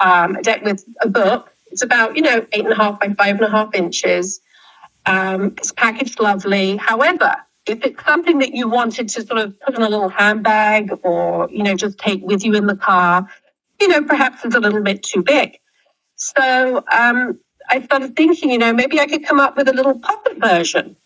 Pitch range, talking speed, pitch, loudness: 200-270 Hz, 210 wpm, 225 Hz, -16 LUFS